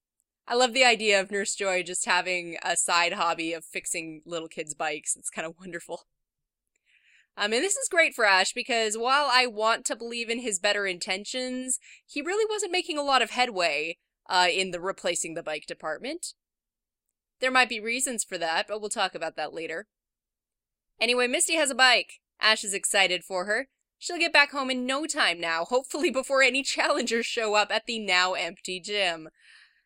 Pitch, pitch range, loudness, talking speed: 210 Hz, 180-255 Hz, -25 LUFS, 190 wpm